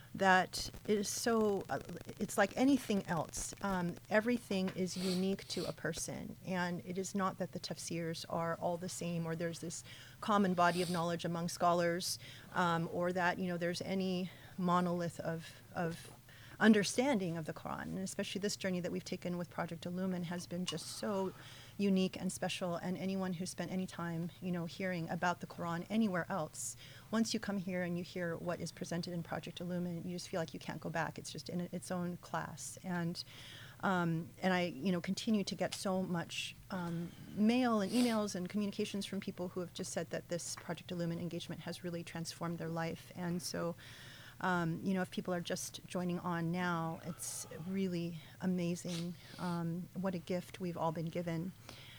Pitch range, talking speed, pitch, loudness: 165-185 Hz, 190 wpm, 175 Hz, -38 LUFS